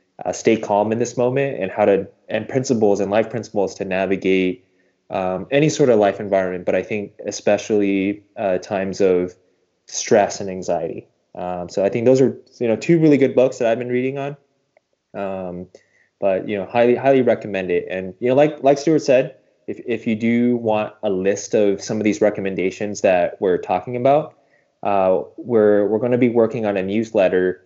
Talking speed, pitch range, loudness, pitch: 195 wpm, 95-125 Hz, -19 LUFS, 105 Hz